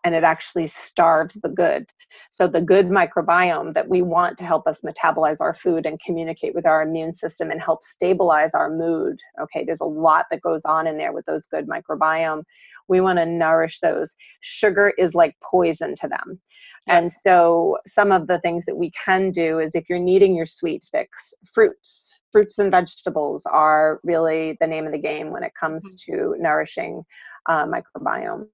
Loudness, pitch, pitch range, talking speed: -20 LUFS, 170 Hz, 160-190 Hz, 185 wpm